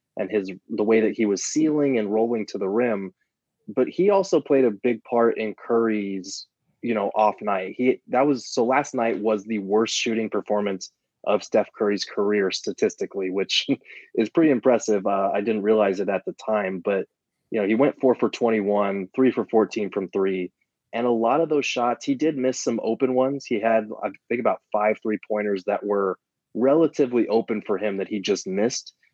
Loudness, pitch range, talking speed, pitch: -23 LUFS, 100-125 Hz, 200 wpm, 110 Hz